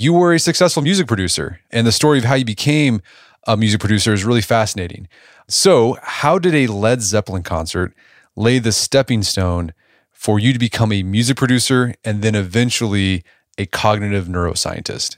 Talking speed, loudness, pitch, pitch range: 170 wpm, -16 LUFS, 110 Hz, 100-125 Hz